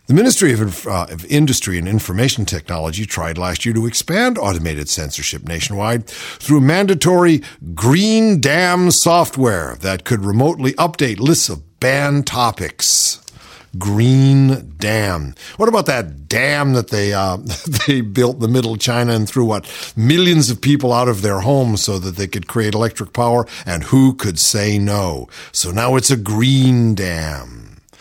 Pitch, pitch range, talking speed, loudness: 115 Hz, 95-135 Hz, 160 wpm, -15 LUFS